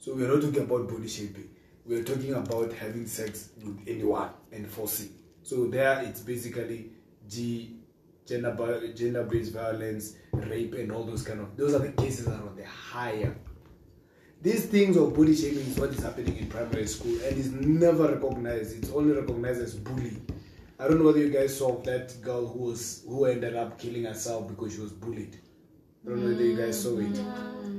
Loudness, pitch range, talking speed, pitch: -29 LUFS, 110-130 Hz, 190 wpm, 115 Hz